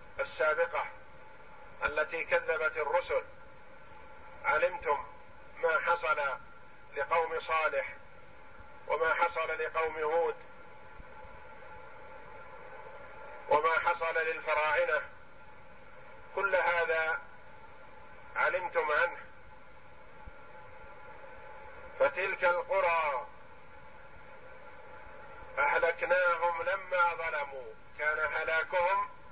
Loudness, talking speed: -31 LUFS, 55 wpm